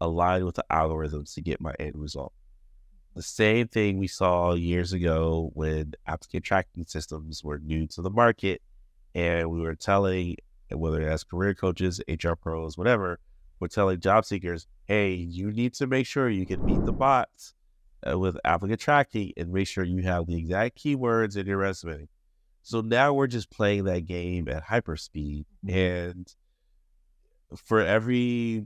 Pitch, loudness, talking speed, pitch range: 90 Hz, -27 LUFS, 165 wpm, 80-100 Hz